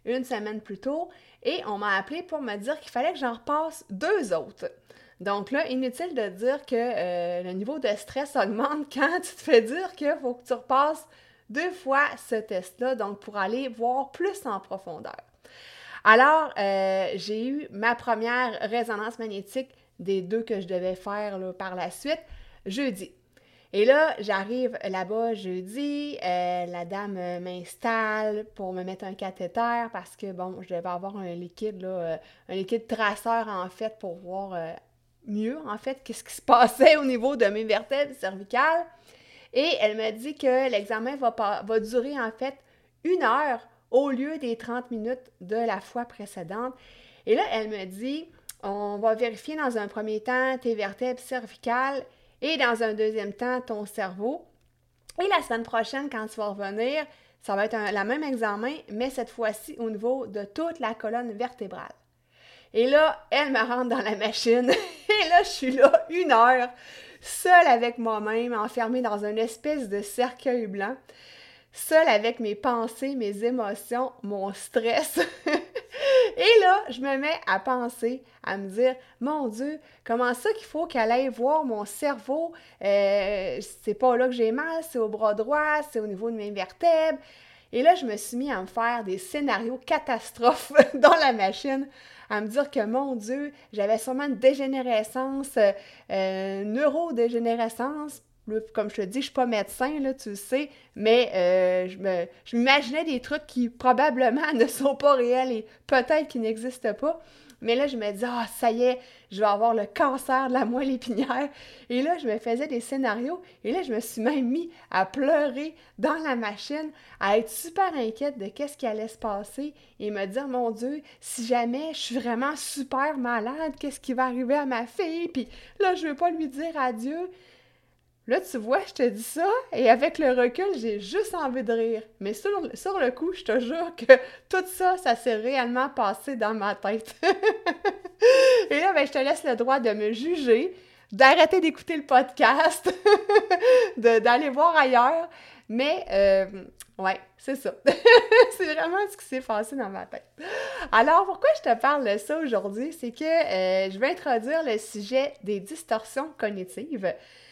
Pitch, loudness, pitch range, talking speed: 250 Hz, -25 LUFS, 215-290 Hz, 180 wpm